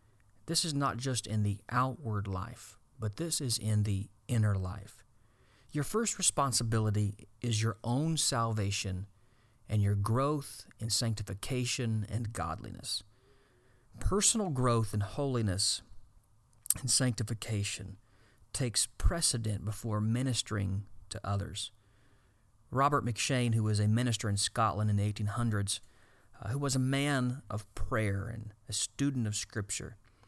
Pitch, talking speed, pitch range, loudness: 110 Hz, 125 wpm, 105-125 Hz, -32 LUFS